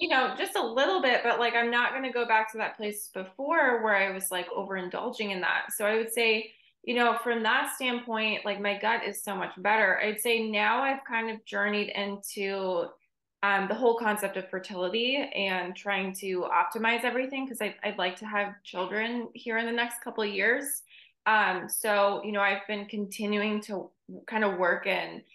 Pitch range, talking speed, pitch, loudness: 200-235 Hz, 200 wpm, 210 Hz, -28 LUFS